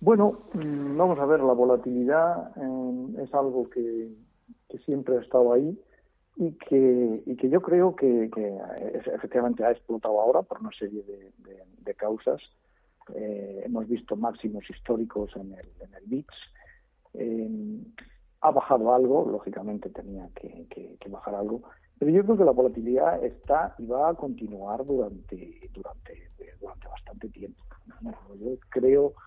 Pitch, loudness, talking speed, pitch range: 125 Hz, -26 LUFS, 155 wpm, 110-155 Hz